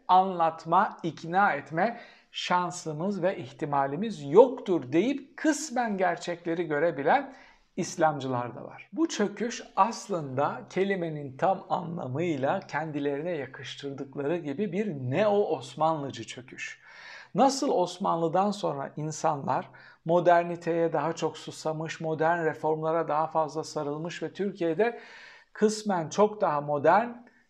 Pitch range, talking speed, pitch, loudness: 155-195 Hz, 100 wpm, 170 Hz, -28 LUFS